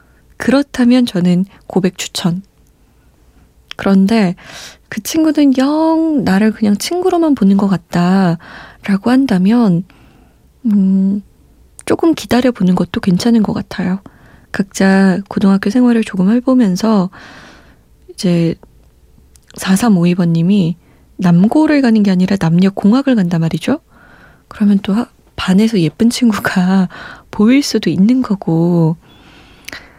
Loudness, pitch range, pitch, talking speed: -13 LUFS, 180-235 Hz, 200 Hz, 225 characters per minute